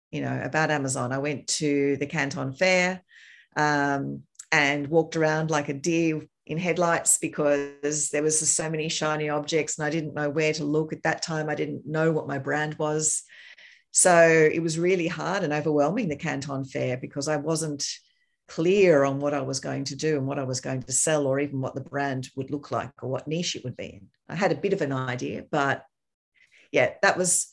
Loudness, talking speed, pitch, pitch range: -25 LUFS, 210 wpm, 150 Hz, 140-160 Hz